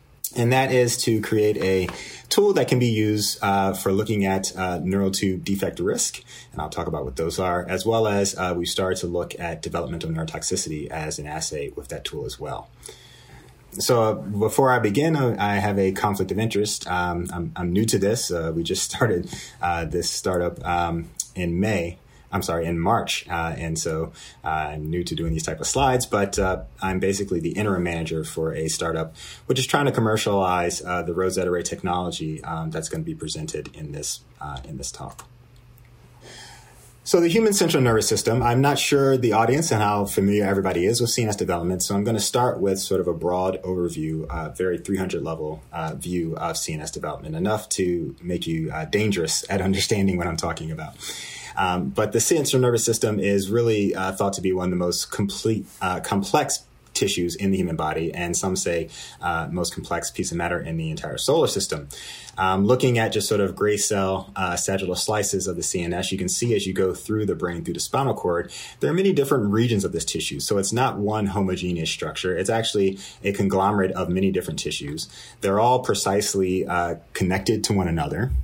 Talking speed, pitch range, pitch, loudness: 205 wpm, 85-110 Hz, 95 Hz, -23 LUFS